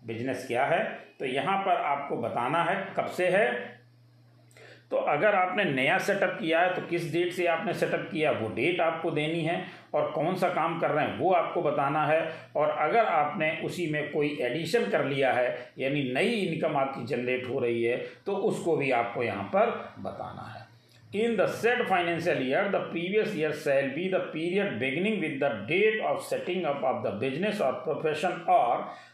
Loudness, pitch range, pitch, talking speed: -28 LUFS, 125-180 Hz, 160 Hz, 185 wpm